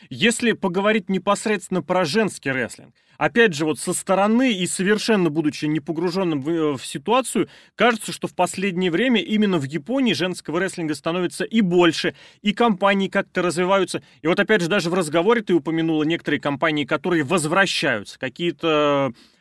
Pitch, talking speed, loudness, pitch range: 180 Hz, 150 wpm, -21 LUFS, 165-205 Hz